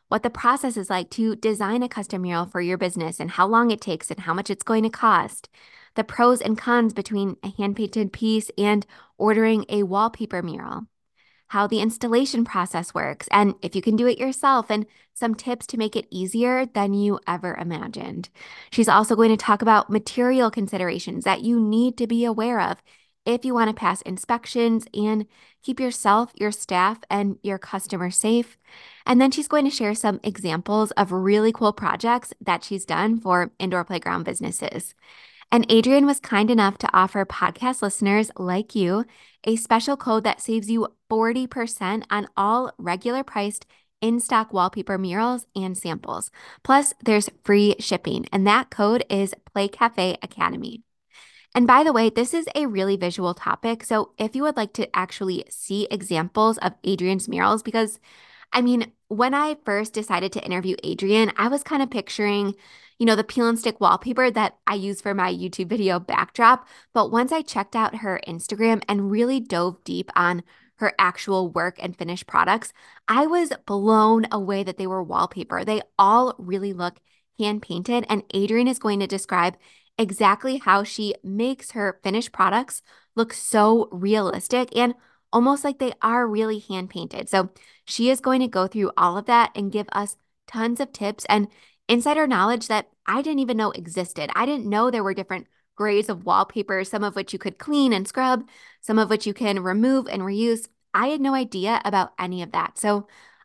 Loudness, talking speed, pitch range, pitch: -22 LUFS, 185 wpm, 195-235 Hz, 215 Hz